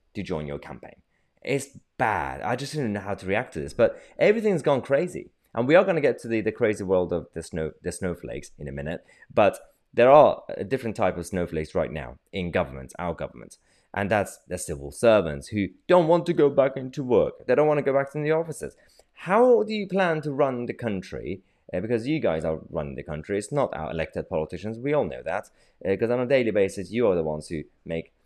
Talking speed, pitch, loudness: 235 wpm, 105 Hz, -25 LUFS